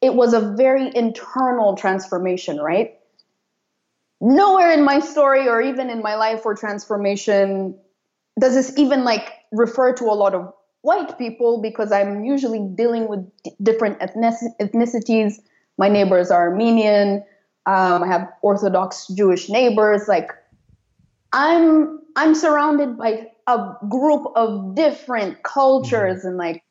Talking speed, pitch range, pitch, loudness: 130 wpm, 200-260 Hz, 225 Hz, -18 LUFS